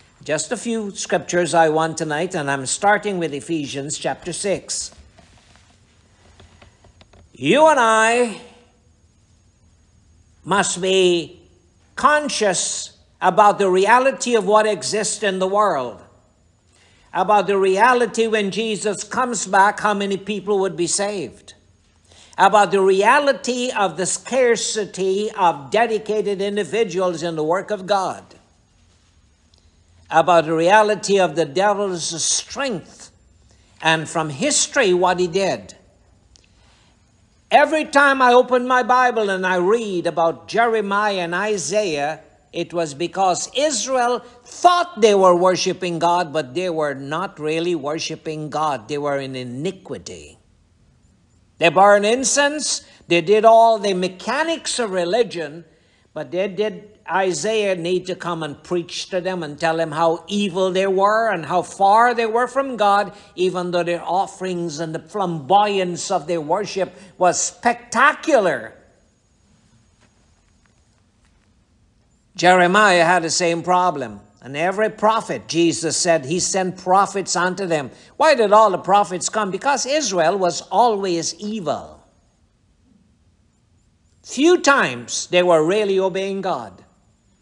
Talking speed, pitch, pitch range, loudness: 125 wpm, 180 Hz, 145-210 Hz, -18 LUFS